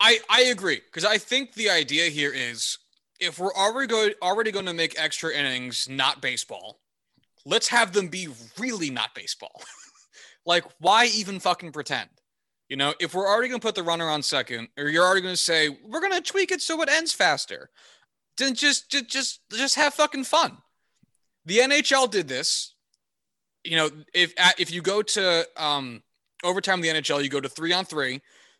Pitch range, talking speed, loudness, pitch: 155-250 Hz, 190 wpm, -23 LUFS, 185 Hz